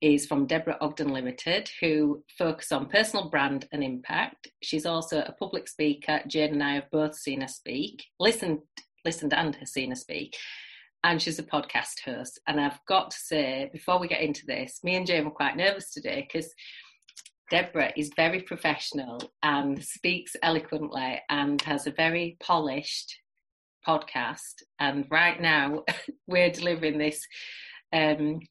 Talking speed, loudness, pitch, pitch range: 160 wpm, -28 LUFS, 155 Hz, 145-170 Hz